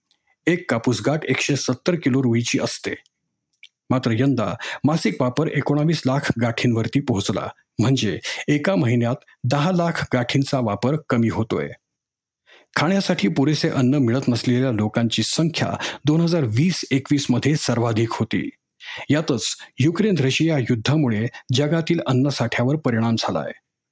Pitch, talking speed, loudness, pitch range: 135 Hz, 120 wpm, -21 LUFS, 120-150 Hz